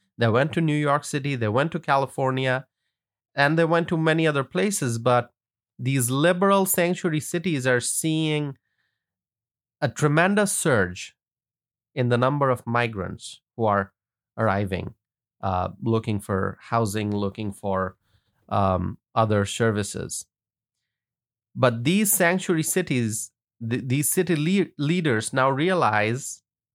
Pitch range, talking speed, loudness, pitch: 110-150 Hz, 125 wpm, -23 LUFS, 125 Hz